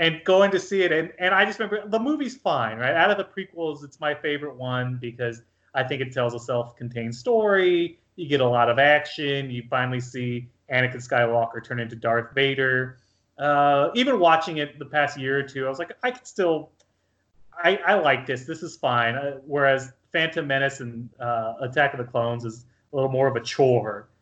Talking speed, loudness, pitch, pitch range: 210 wpm, -23 LUFS, 135 Hz, 120-160 Hz